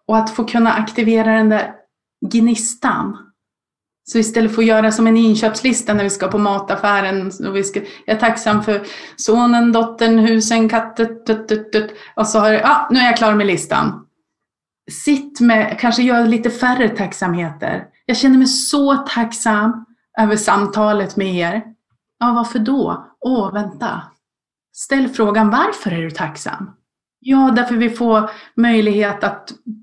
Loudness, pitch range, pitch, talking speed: -15 LUFS, 210-235 Hz, 225 Hz, 155 wpm